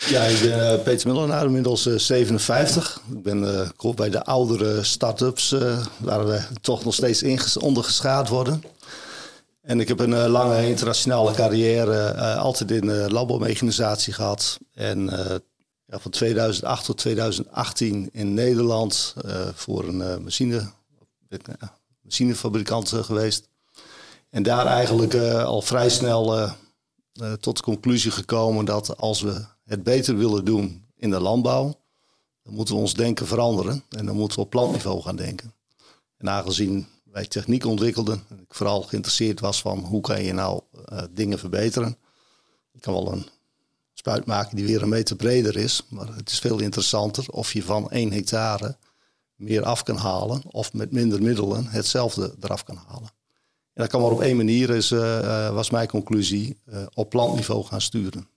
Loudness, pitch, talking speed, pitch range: -23 LUFS, 110 Hz, 170 wpm, 105-120 Hz